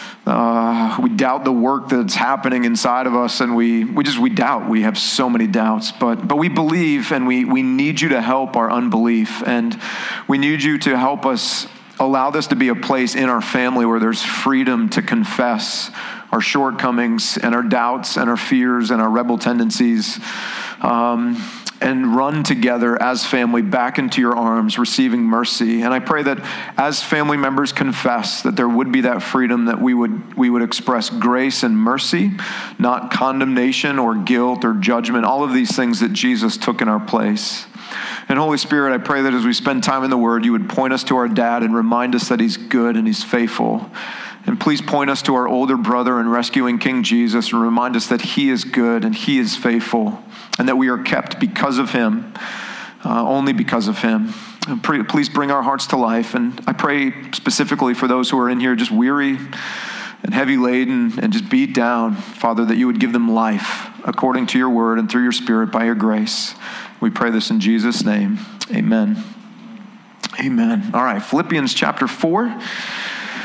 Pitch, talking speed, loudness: 145 Hz, 195 wpm, -17 LUFS